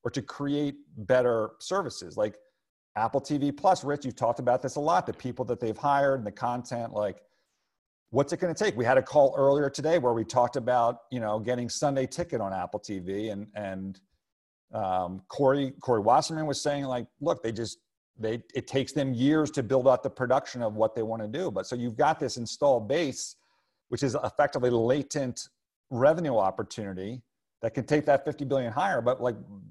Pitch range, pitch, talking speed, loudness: 115-140 Hz, 130 Hz, 200 wpm, -28 LUFS